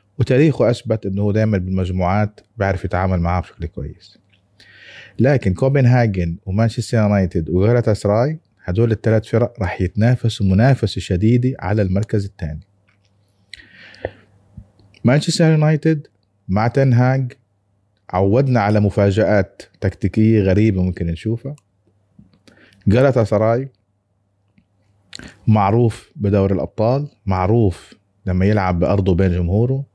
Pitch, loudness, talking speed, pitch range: 105 Hz, -17 LUFS, 95 wpm, 95-115 Hz